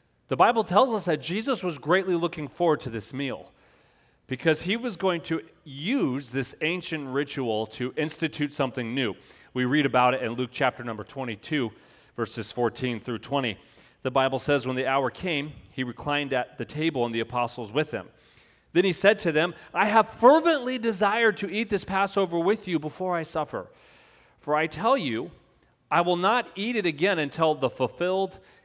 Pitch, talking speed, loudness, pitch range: 155 Hz, 180 wpm, -26 LUFS, 130-185 Hz